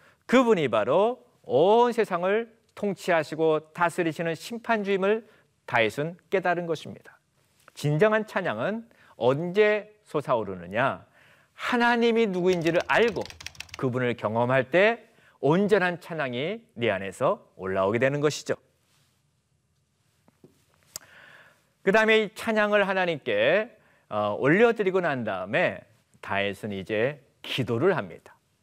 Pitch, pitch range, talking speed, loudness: 185 Hz, 150-215 Hz, 245 characters per minute, -25 LUFS